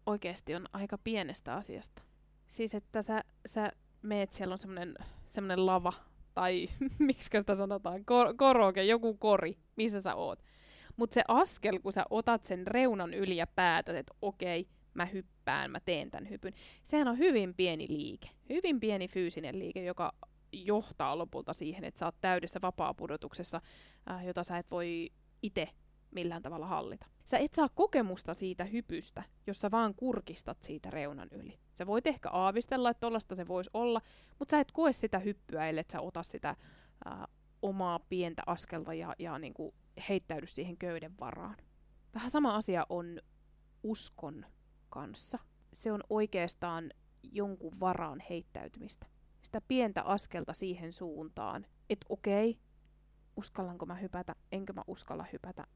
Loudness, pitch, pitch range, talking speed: -35 LUFS, 195 Hz, 175-225 Hz, 150 wpm